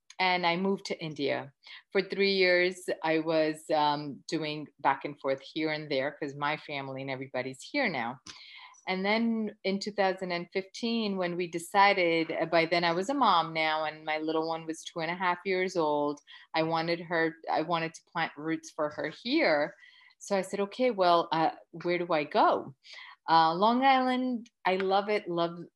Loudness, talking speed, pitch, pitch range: -29 LUFS, 180 wpm, 170 Hz, 155-195 Hz